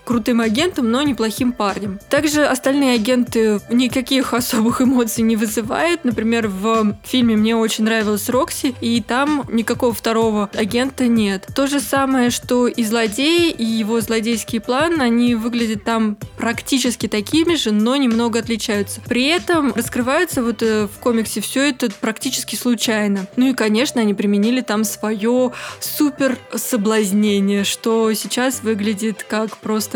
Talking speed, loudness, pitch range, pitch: 140 wpm, -18 LUFS, 220-255 Hz, 235 Hz